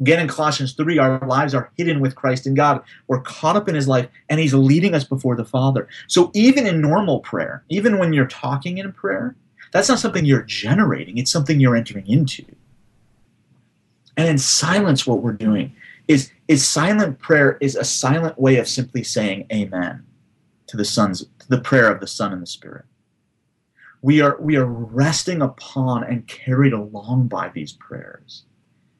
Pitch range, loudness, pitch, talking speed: 125-155 Hz, -18 LUFS, 135 Hz, 185 wpm